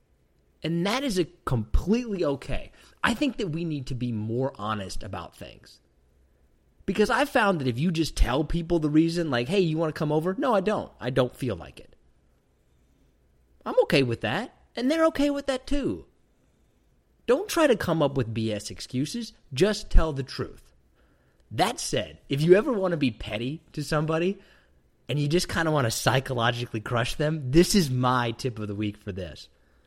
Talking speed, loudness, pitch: 190 wpm, -26 LUFS, 135 Hz